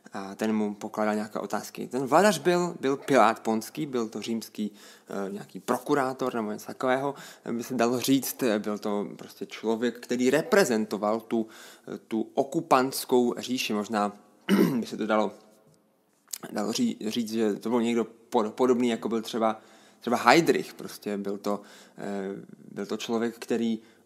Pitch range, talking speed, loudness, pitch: 105-130 Hz, 150 wpm, -27 LUFS, 115 Hz